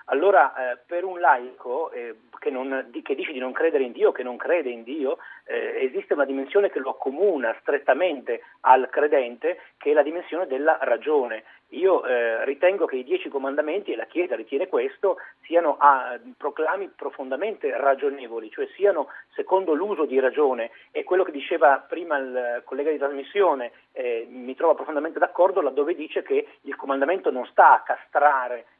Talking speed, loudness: 170 wpm, -23 LUFS